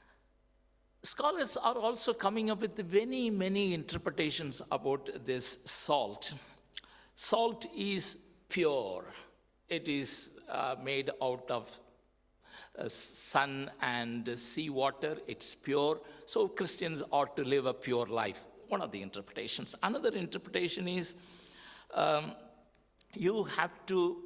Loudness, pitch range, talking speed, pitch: -34 LUFS, 130-200 Hz, 115 wpm, 165 Hz